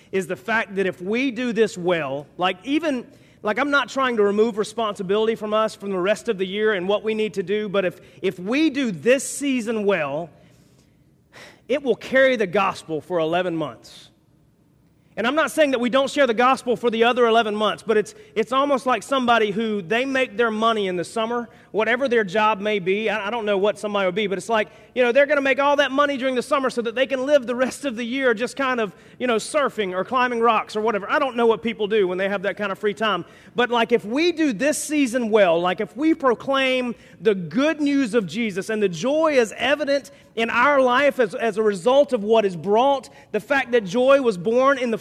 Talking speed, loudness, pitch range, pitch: 240 wpm, -21 LUFS, 210-260 Hz, 230 Hz